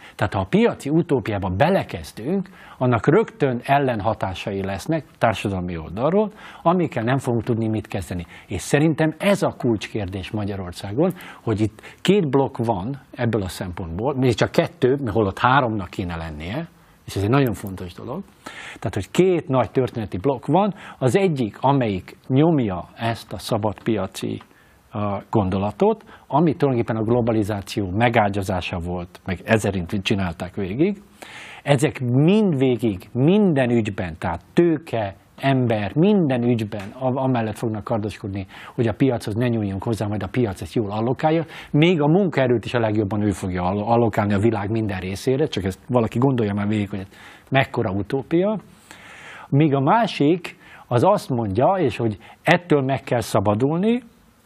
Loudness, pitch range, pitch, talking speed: -21 LUFS, 105-145 Hz, 120 Hz, 145 wpm